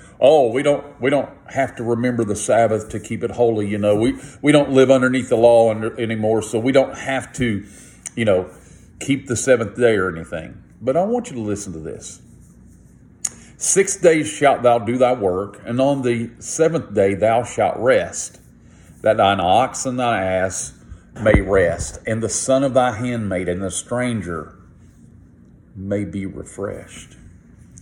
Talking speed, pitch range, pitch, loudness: 175 wpm, 105-135 Hz, 120 Hz, -19 LUFS